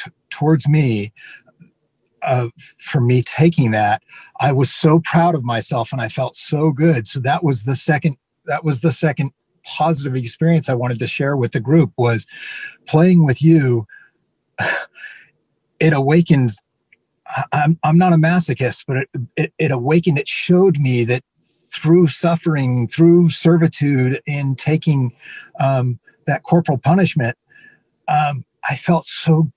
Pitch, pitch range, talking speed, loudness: 145 Hz, 130-160 Hz, 140 wpm, -17 LUFS